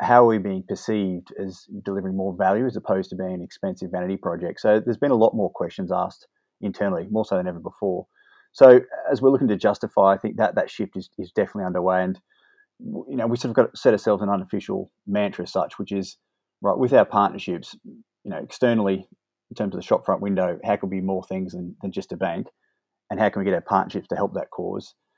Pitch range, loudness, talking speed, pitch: 95-110 Hz, -23 LUFS, 235 wpm, 95 Hz